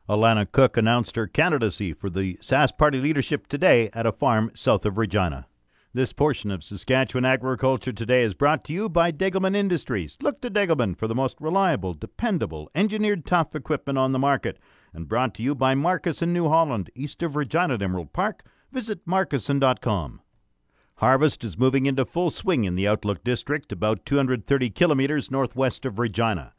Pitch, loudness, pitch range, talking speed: 130 Hz, -24 LUFS, 110-150 Hz, 175 wpm